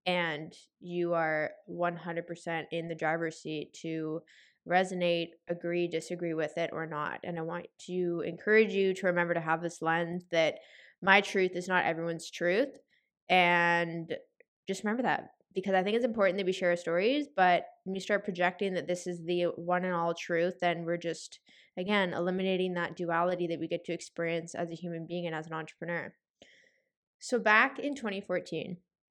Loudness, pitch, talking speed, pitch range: -31 LUFS, 175 Hz, 175 wpm, 170-190 Hz